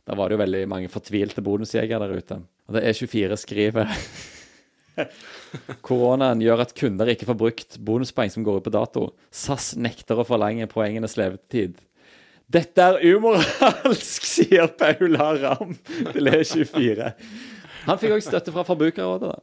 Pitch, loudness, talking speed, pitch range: 115 Hz, -22 LUFS, 150 wpm, 105-150 Hz